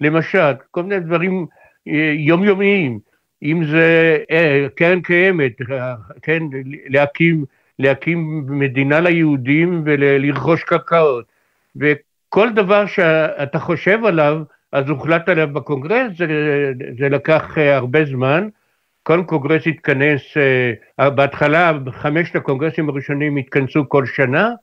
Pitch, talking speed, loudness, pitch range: 155 Hz, 95 wpm, -16 LUFS, 140-170 Hz